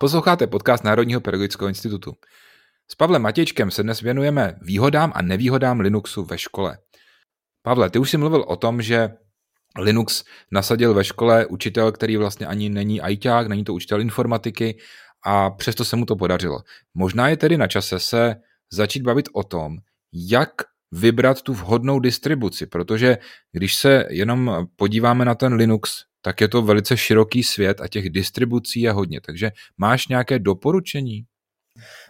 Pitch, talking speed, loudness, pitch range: 110 Hz, 155 wpm, -20 LUFS, 100-125 Hz